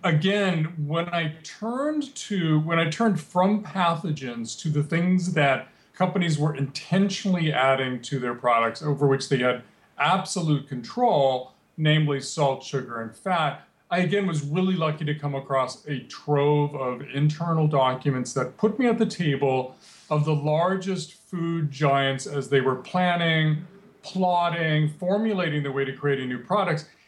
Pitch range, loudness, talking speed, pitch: 140-180 Hz, -25 LUFS, 155 wpm, 155 Hz